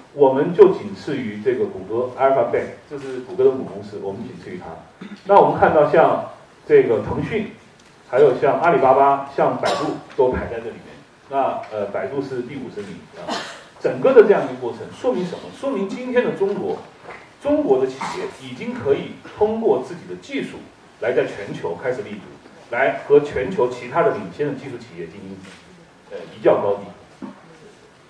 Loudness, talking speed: -19 LUFS, 285 characters per minute